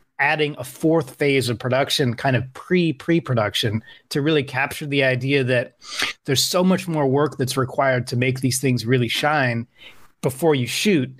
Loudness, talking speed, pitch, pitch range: -21 LUFS, 175 wpm, 135 Hz, 125-150 Hz